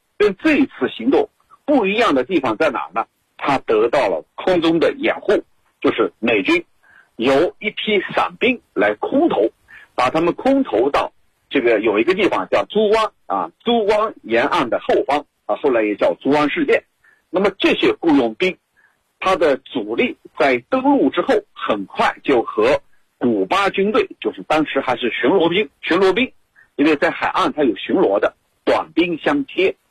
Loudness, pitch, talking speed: -18 LUFS, 260 Hz, 240 characters per minute